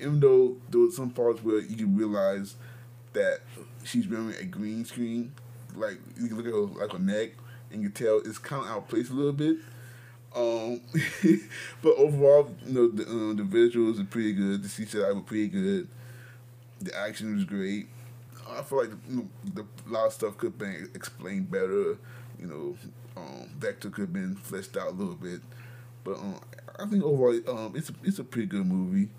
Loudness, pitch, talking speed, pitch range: -29 LUFS, 120 Hz, 200 wpm, 110-145 Hz